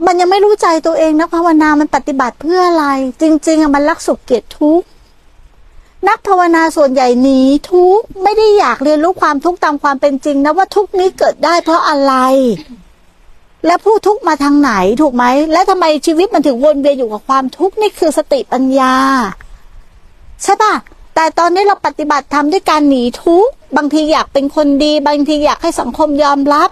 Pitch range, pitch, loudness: 285-350 Hz, 310 Hz, -11 LUFS